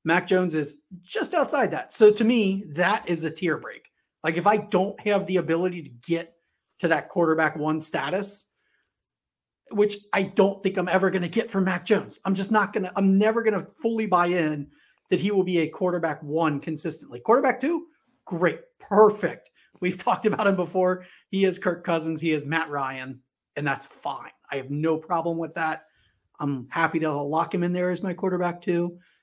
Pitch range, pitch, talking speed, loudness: 160-200 Hz, 180 Hz, 195 wpm, -25 LUFS